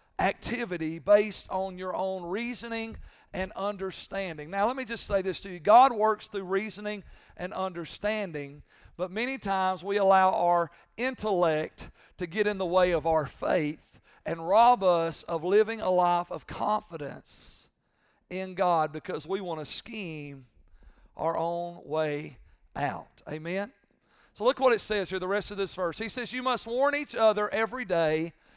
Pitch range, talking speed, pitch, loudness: 165-215 Hz, 165 wpm, 190 Hz, -28 LUFS